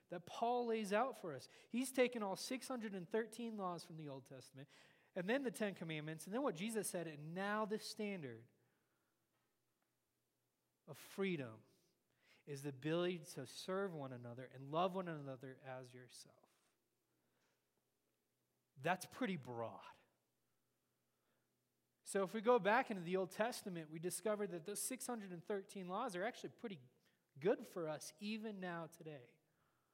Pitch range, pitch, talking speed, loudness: 145-215 Hz, 180 Hz, 140 wpm, -44 LUFS